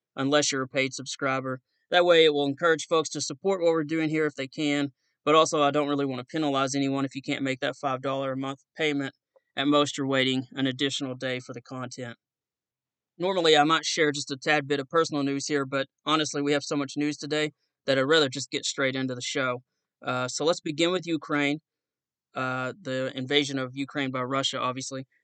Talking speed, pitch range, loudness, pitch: 215 wpm, 135-150 Hz, -26 LUFS, 140 Hz